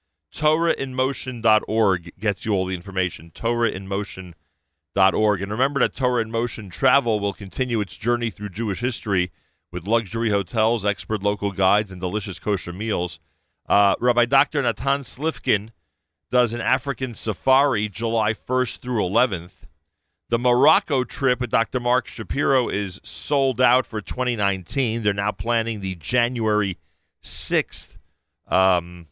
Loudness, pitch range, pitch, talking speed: -22 LUFS, 95-120 Hz, 105 Hz, 130 wpm